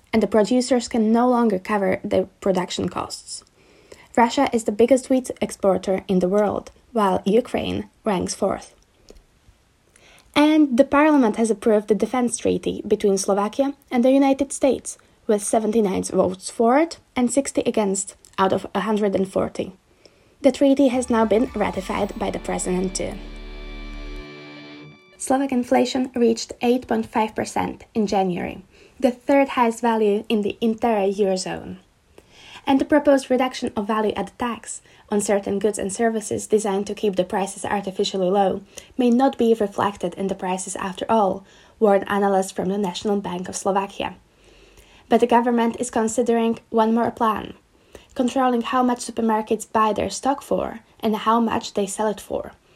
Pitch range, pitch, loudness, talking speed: 195-245 Hz, 220 Hz, -21 LUFS, 150 wpm